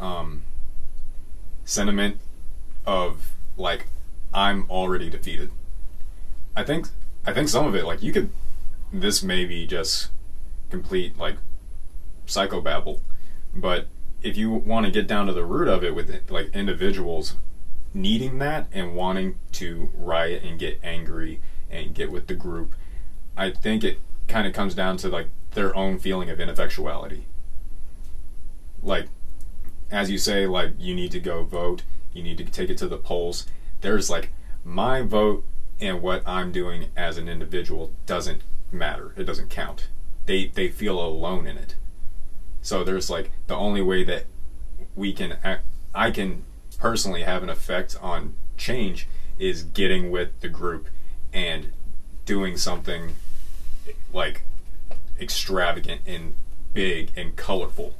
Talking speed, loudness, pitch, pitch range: 145 wpm, -27 LUFS, 85 Hz, 70-95 Hz